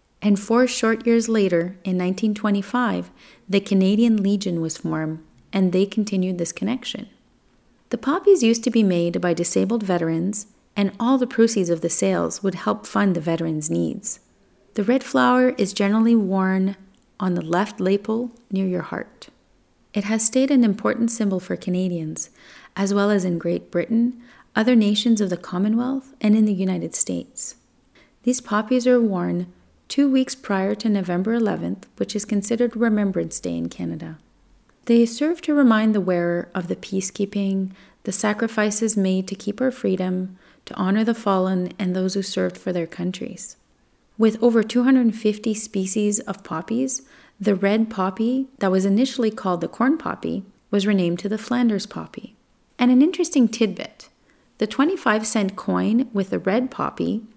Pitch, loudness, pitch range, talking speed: 210 Hz, -21 LUFS, 185-235 Hz, 160 wpm